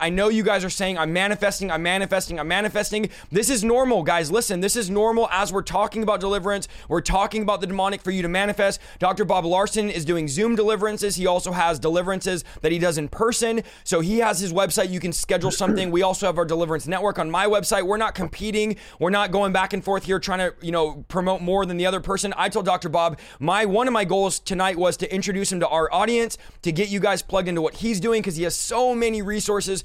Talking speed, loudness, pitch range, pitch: 240 wpm, -22 LUFS, 180-210 Hz, 195 Hz